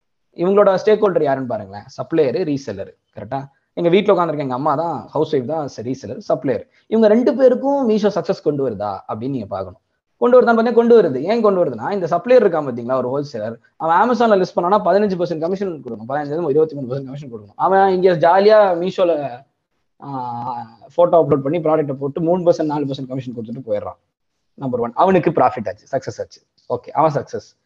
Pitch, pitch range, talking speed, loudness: 165 Hz, 135-195 Hz, 155 wpm, -17 LUFS